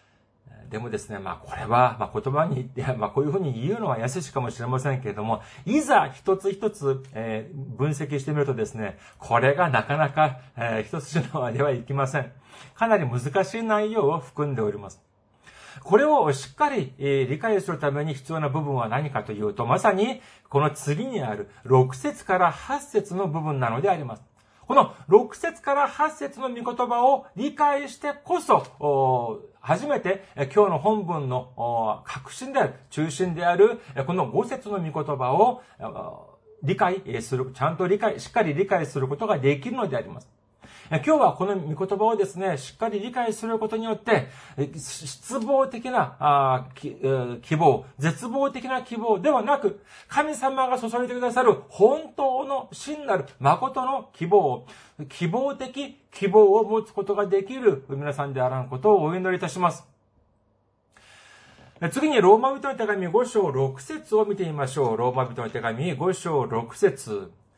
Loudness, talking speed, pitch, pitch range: -24 LUFS, 310 characters per minute, 170 Hz, 135-225 Hz